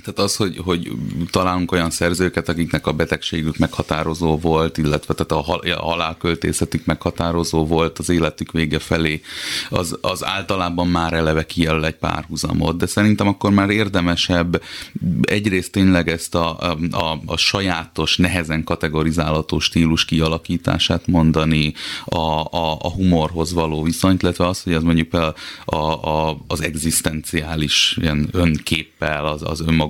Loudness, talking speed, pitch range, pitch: -19 LUFS, 135 wpm, 80-85 Hz, 80 Hz